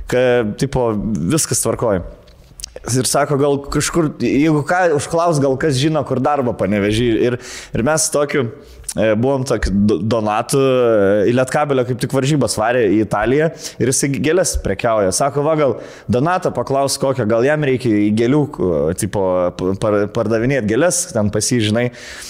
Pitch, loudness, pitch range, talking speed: 130 Hz, -16 LUFS, 115-145 Hz, 135 wpm